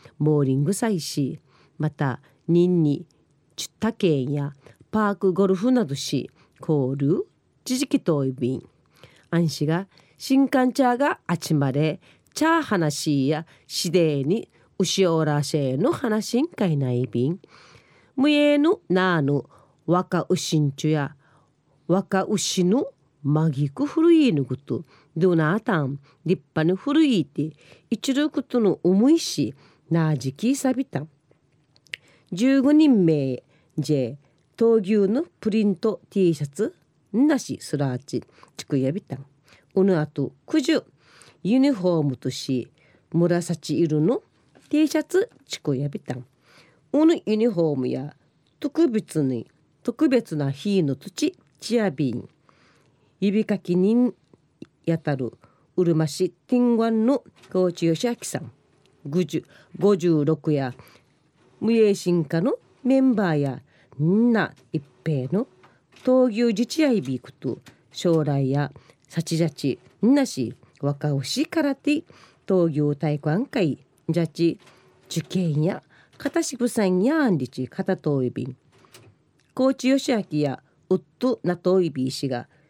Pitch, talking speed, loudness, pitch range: 165 Hz, 225 characters per minute, -23 LUFS, 145-220 Hz